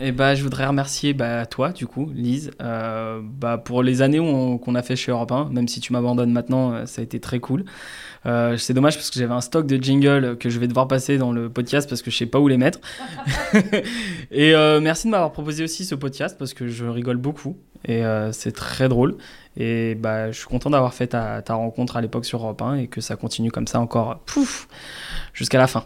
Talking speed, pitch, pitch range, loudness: 240 wpm, 125 Hz, 120-140 Hz, -21 LUFS